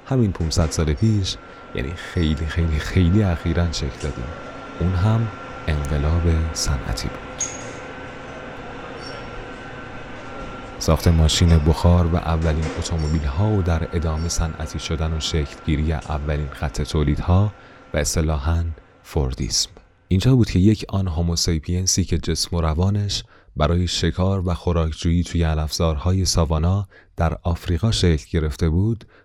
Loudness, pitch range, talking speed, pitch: -21 LUFS, 80-95 Hz, 125 wpm, 85 Hz